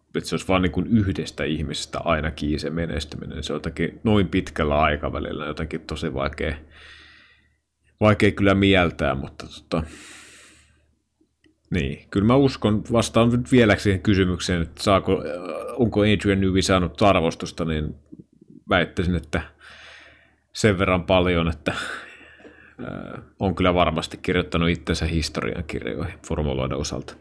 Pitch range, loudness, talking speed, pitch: 80-100 Hz, -22 LUFS, 120 wpm, 90 Hz